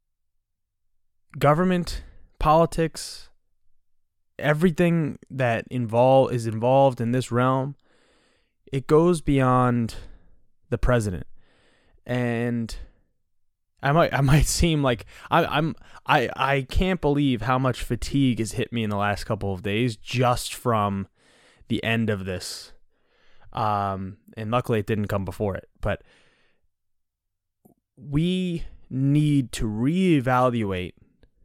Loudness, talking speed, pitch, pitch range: -24 LUFS, 115 wpm, 120 Hz, 100-135 Hz